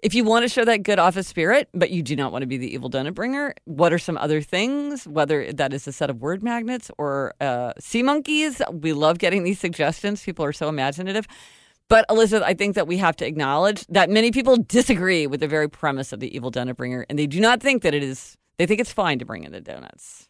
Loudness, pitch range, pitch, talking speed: -21 LUFS, 145-225 Hz, 175 Hz, 250 wpm